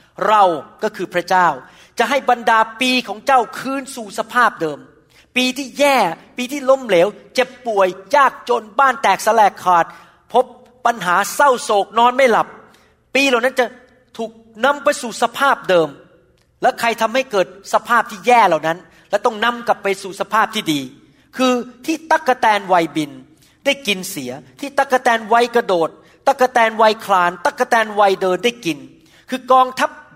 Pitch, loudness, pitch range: 230 Hz, -16 LUFS, 190-255 Hz